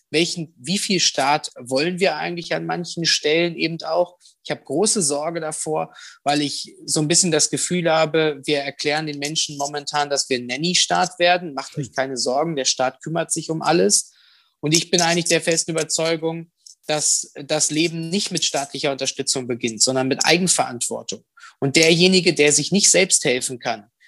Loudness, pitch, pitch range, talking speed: -19 LUFS, 160 Hz, 145-170 Hz, 175 wpm